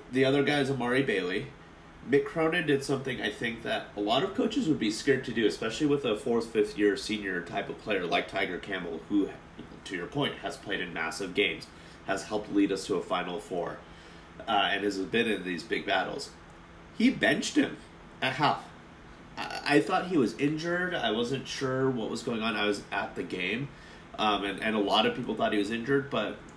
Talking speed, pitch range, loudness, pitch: 210 wpm, 95-140 Hz, -29 LUFS, 115 Hz